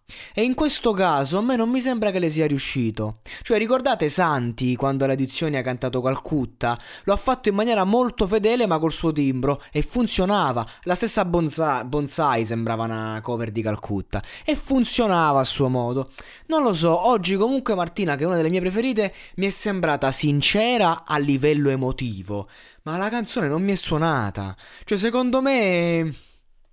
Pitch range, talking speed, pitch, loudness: 130-215 Hz, 175 wpm, 165 Hz, -22 LUFS